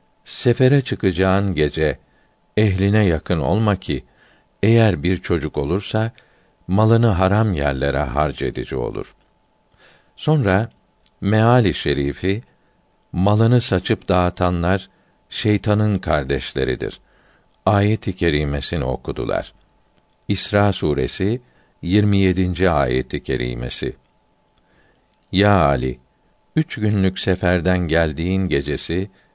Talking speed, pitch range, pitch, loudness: 80 wpm, 75-105 Hz, 95 Hz, -19 LUFS